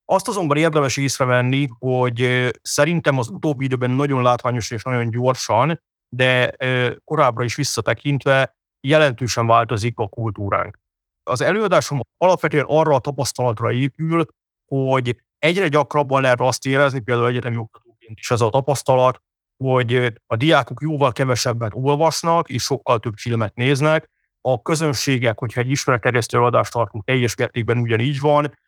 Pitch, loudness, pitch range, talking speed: 130 Hz, -19 LUFS, 120-145 Hz, 135 wpm